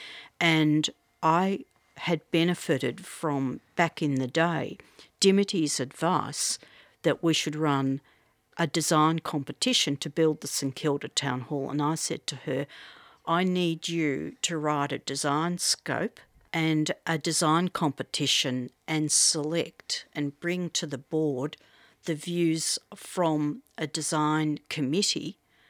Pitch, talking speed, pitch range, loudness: 155 Hz, 130 wpm, 145-170 Hz, -27 LUFS